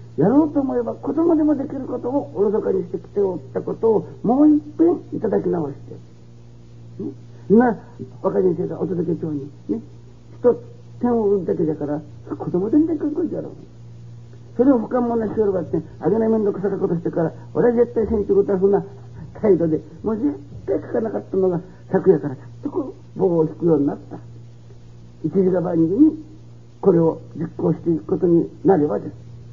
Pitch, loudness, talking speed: 180 Hz, -20 LUFS, 365 characters per minute